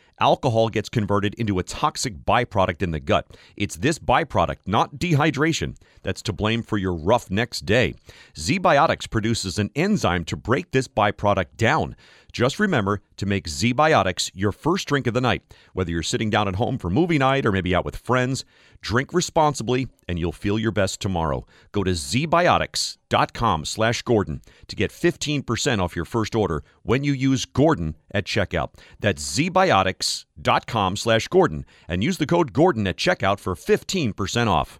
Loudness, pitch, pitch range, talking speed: -22 LUFS, 110 Hz, 95-130 Hz, 160 wpm